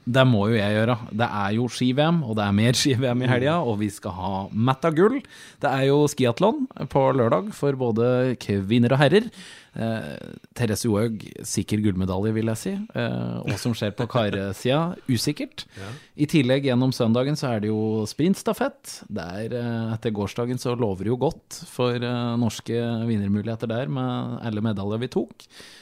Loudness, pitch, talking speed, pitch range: -24 LUFS, 120 Hz, 175 wpm, 110-135 Hz